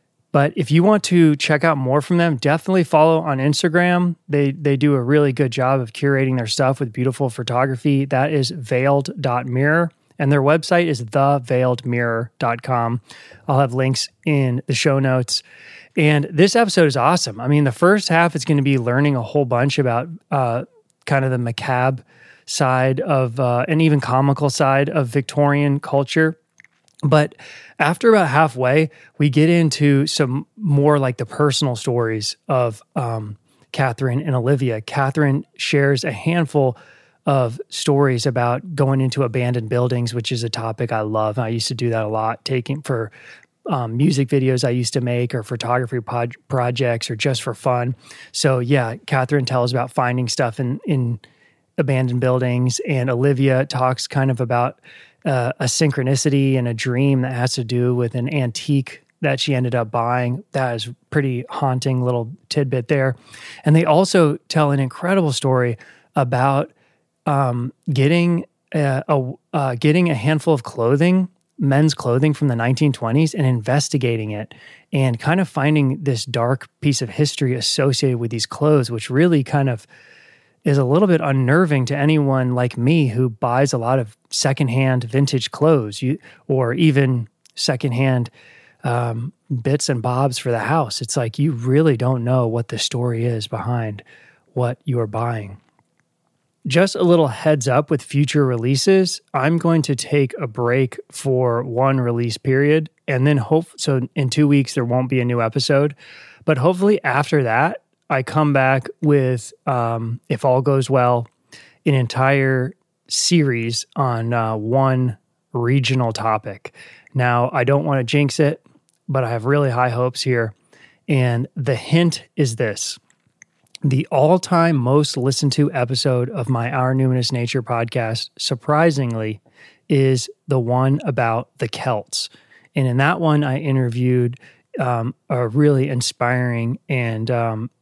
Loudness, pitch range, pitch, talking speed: -19 LUFS, 125-150 Hz, 135 Hz, 160 wpm